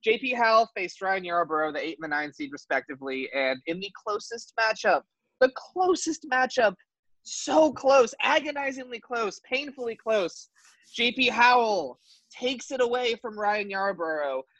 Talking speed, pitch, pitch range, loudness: 140 wpm, 230 Hz, 175-255 Hz, -26 LUFS